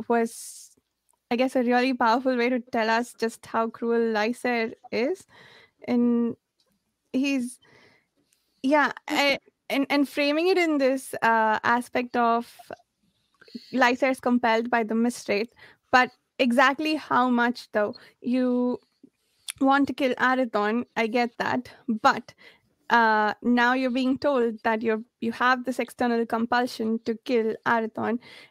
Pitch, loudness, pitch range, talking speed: 245 Hz, -24 LUFS, 230-260 Hz, 135 wpm